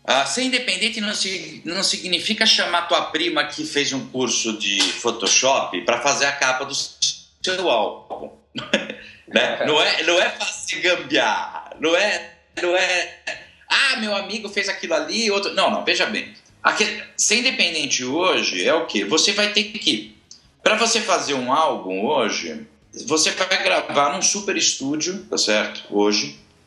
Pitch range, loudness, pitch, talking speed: 140-210 Hz, -19 LUFS, 180 Hz, 160 wpm